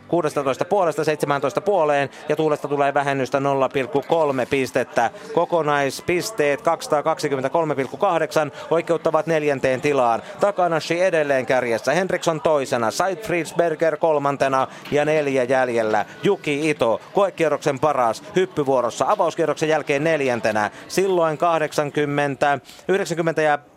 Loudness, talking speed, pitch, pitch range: -21 LUFS, 95 wpm, 150 Hz, 140-165 Hz